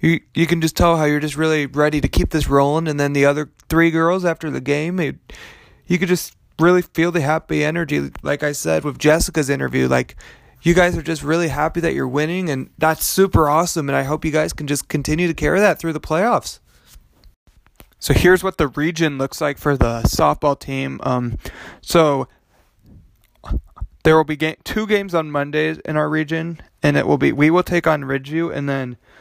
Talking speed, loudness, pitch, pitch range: 205 wpm, -18 LUFS, 155 Hz, 145-165 Hz